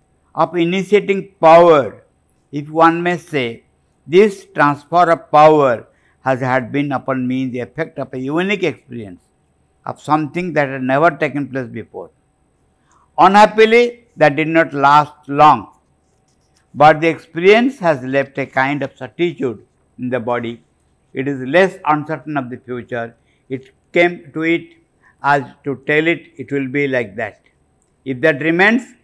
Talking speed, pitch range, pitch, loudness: 145 wpm, 130-165 Hz, 145 Hz, -15 LUFS